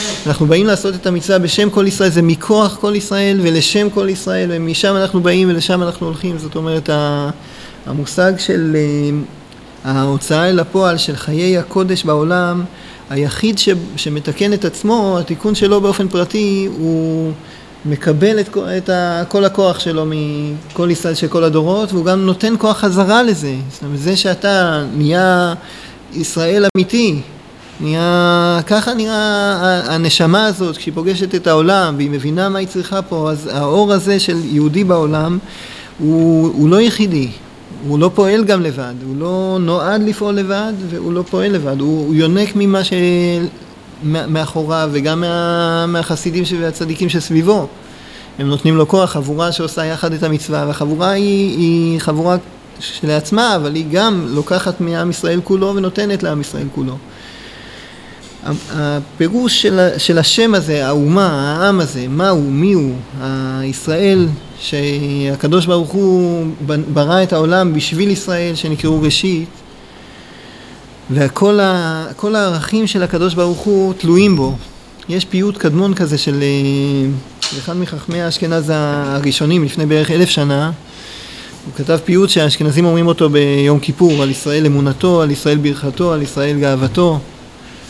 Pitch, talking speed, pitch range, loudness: 170 Hz, 135 wpm, 150-190 Hz, -14 LUFS